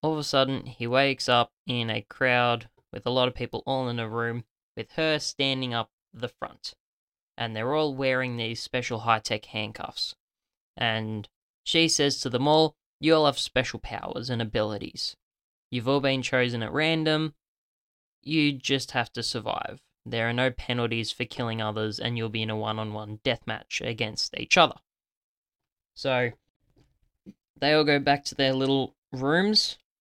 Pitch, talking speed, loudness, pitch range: 125 Hz, 170 wpm, -26 LUFS, 115-140 Hz